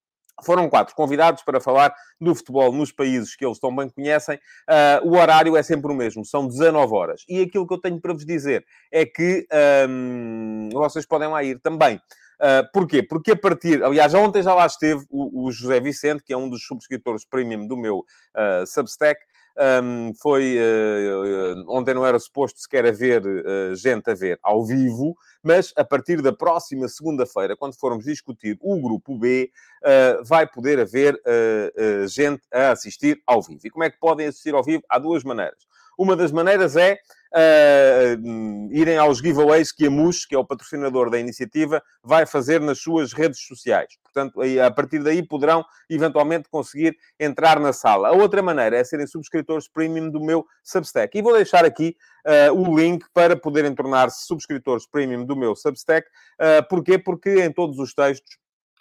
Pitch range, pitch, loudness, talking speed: 130-165 Hz, 150 Hz, -19 LUFS, 180 wpm